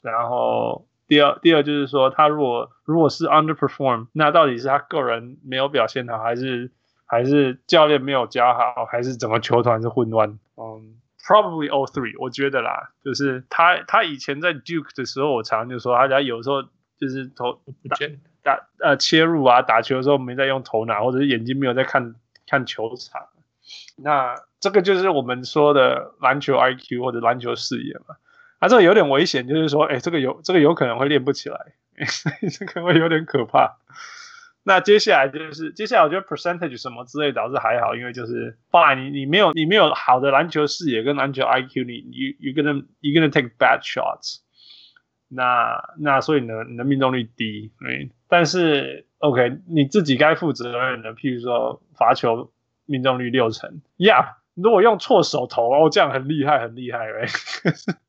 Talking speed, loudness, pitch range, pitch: 340 characters per minute, -19 LUFS, 125-155 Hz, 135 Hz